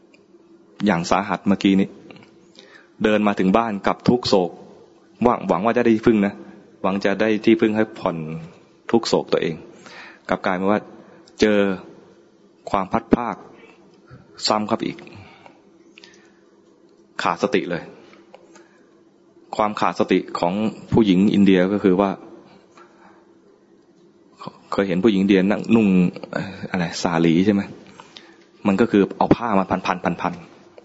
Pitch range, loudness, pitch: 95-105 Hz, -20 LUFS, 100 Hz